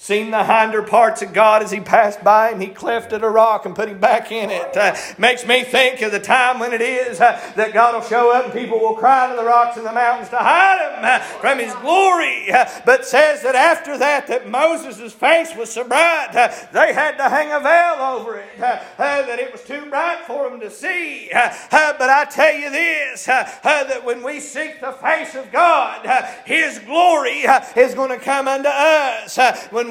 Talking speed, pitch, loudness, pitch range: 230 wpm, 260 Hz, -16 LUFS, 230-305 Hz